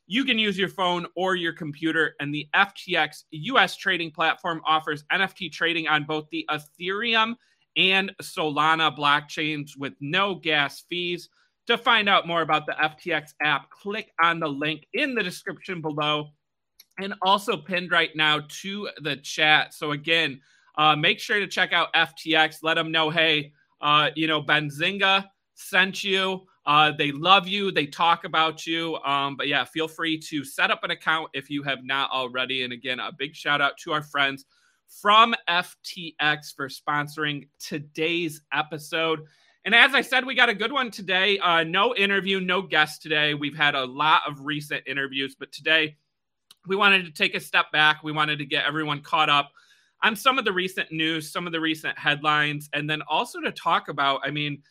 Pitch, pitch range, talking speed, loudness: 160 Hz, 150-185 Hz, 185 wpm, -23 LUFS